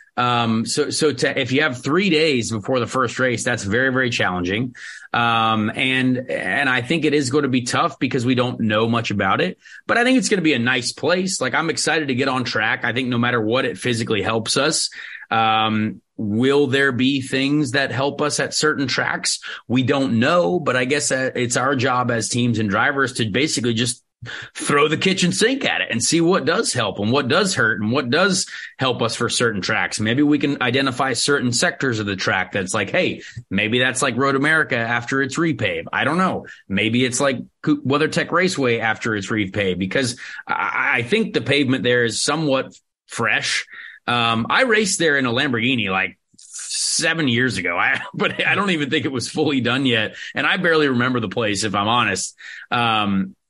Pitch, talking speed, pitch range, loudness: 130 Hz, 205 wpm, 115-145 Hz, -19 LUFS